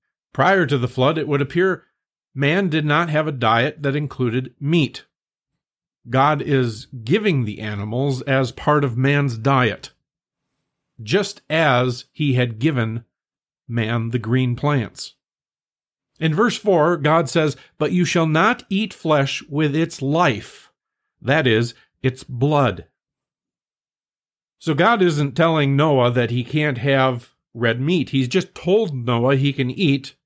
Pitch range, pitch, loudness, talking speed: 125-160 Hz, 140 Hz, -19 LUFS, 140 wpm